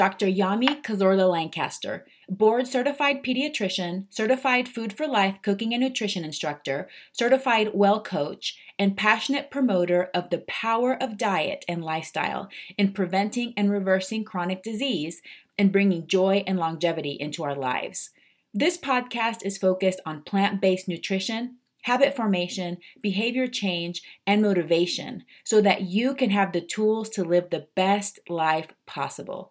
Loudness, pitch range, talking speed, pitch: -25 LUFS, 180-230 Hz, 140 wpm, 200 Hz